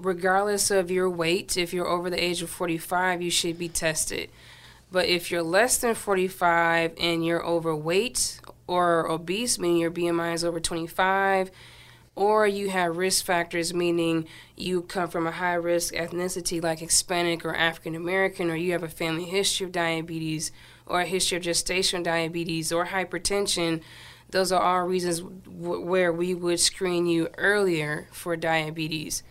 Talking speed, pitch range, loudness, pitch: 160 wpm, 165-185 Hz, -25 LUFS, 175 Hz